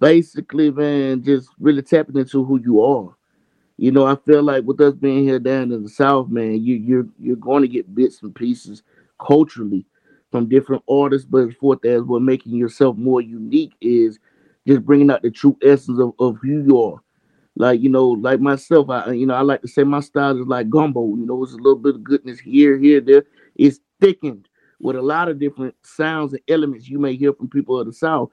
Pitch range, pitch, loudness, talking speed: 125-145 Hz, 135 Hz, -17 LUFS, 220 wpm